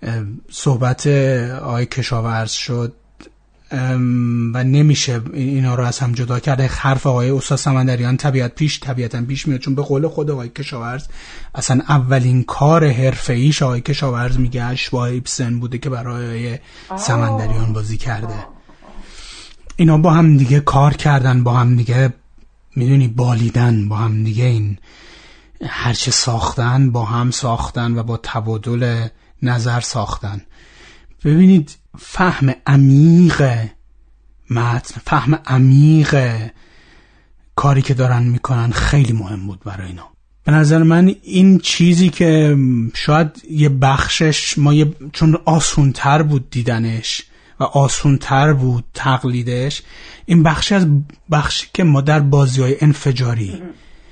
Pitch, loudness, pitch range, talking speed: 130 Hz, -15 LUFS, 120-145 Hz, 125 wpm